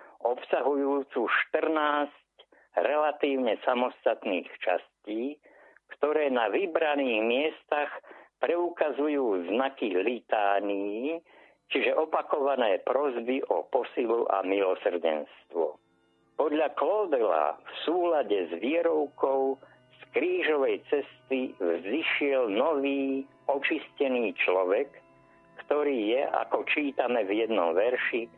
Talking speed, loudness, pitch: 80 wpm, -28 LUFS, 150 Hz